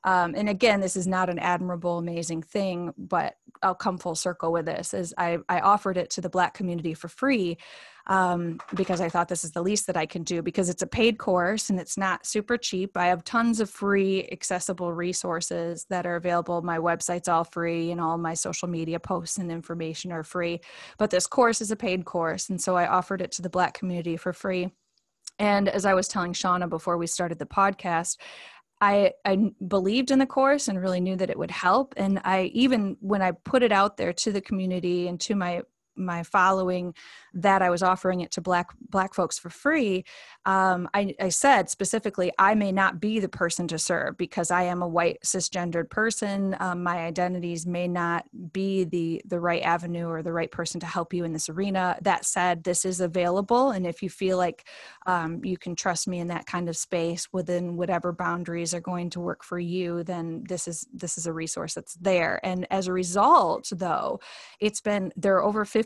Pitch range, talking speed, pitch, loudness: 175-195 Hz, 210 wpm, 180 Hz, -26 LUFS